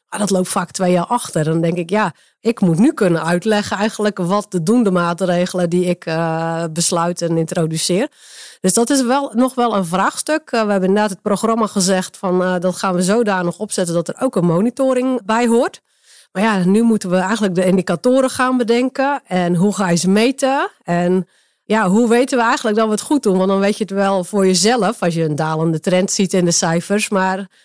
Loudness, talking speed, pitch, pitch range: -16 LUFS, 220 wpm, 195 Hz, 180-230 Hz